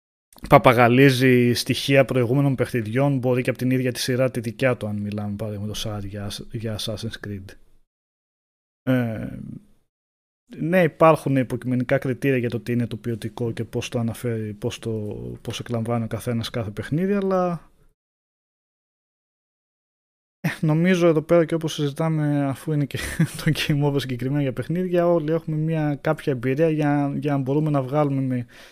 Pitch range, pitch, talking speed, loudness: 115-145 Hz, 130 Hz, 150 wpm, -22 LUFS